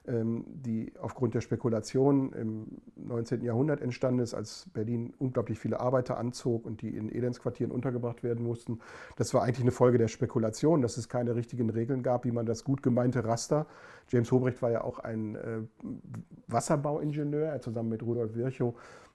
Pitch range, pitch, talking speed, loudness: 115-130 Hz, 120 Hz, 165 wpm, -31 LUFS